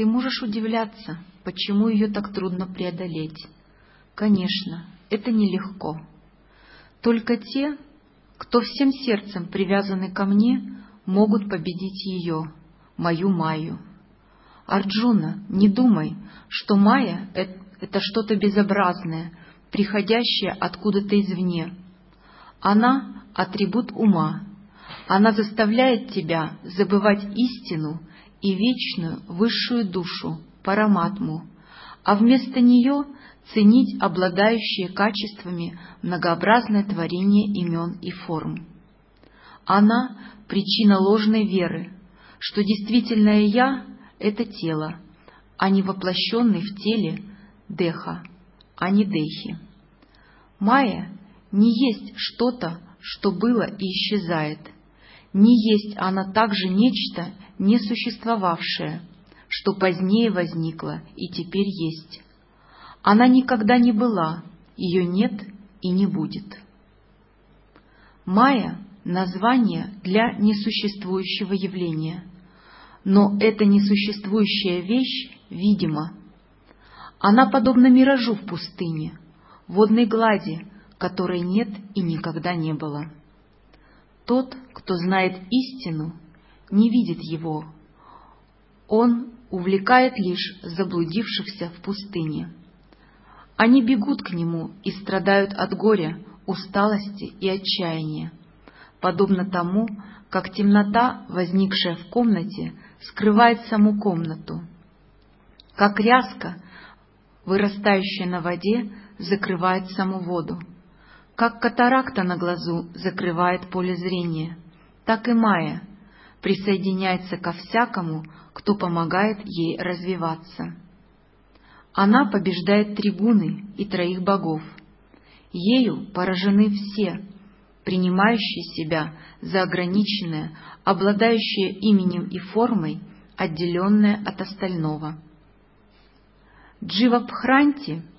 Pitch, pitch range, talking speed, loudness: 195 Hz, 180-215 Hz, 90 wpm, -22 LUFS